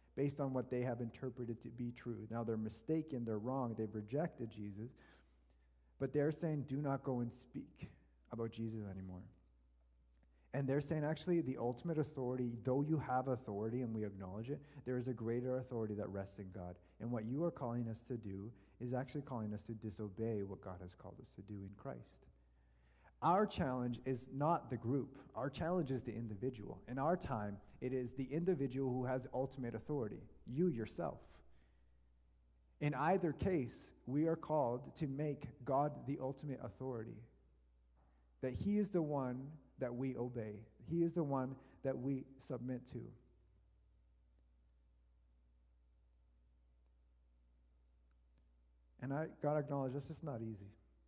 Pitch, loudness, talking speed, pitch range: 120 Hz, -42 LUFS, 160 wpm, 90-135 Hz